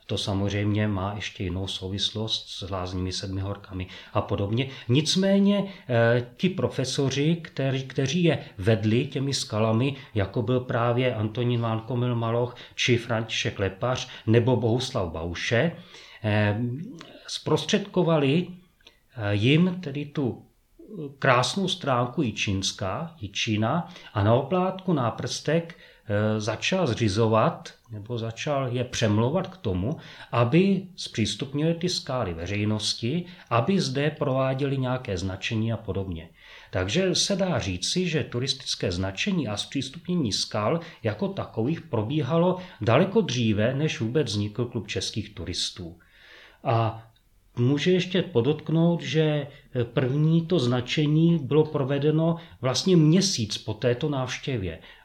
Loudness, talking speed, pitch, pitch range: -26 LUFS, 110 wpm, 125 Hz, 110-155 Hz